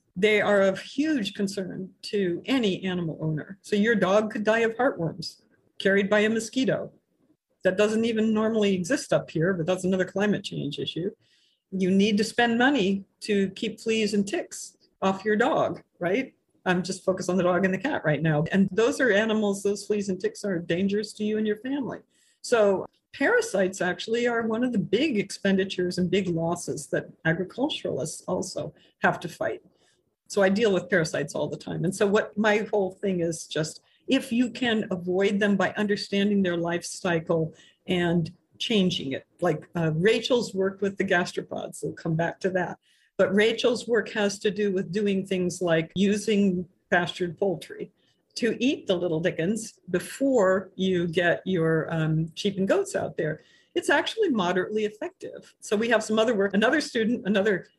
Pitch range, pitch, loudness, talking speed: 180-220 Hz, 195 Hz, -26 LUFS, 180 wpm